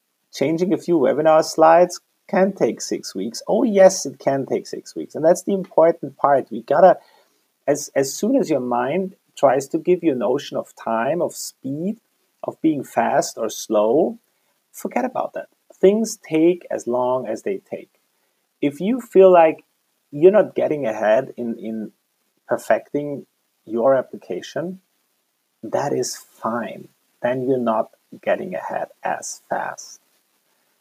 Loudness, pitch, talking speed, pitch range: -20 LUFS, 170 Hz, 150 wpm, 135-200 Hz